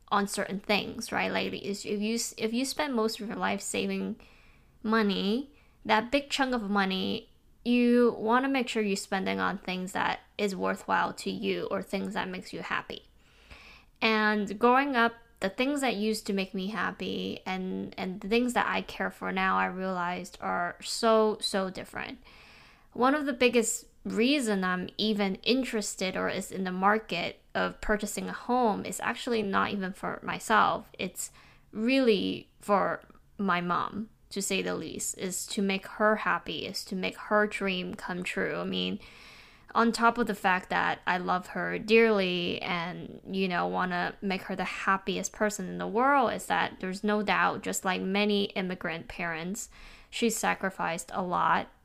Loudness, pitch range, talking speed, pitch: -29 LUFS, 185-225 Hz, 175 wpm, 205 Hz